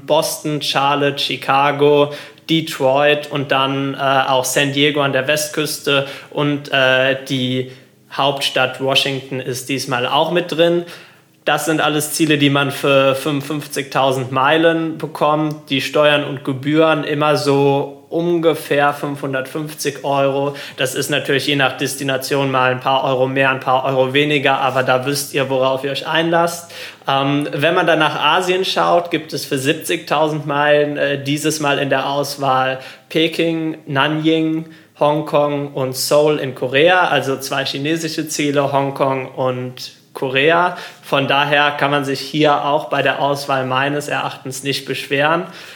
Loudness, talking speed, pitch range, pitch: -16 LUFS, 145 wpm, 135-150 Hz, 140 Hz